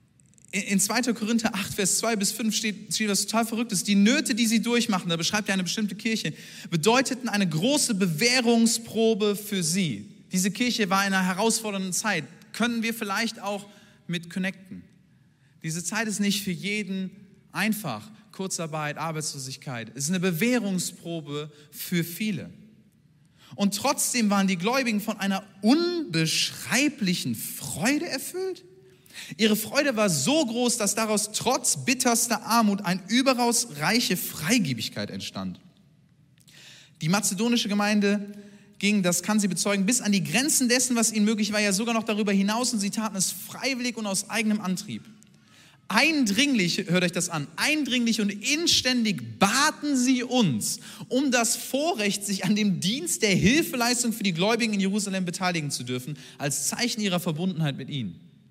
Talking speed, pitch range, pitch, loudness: 150 wpm, 180-230 Hz, 205 Hz, -25 LUFS